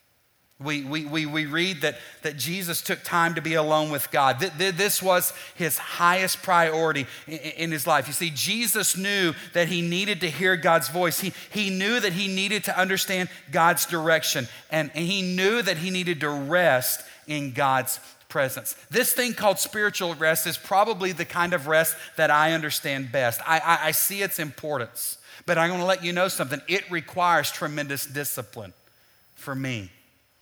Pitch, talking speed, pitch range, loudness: 165 Hz, 185 wpm, 150-185 Hz, -24 LUFS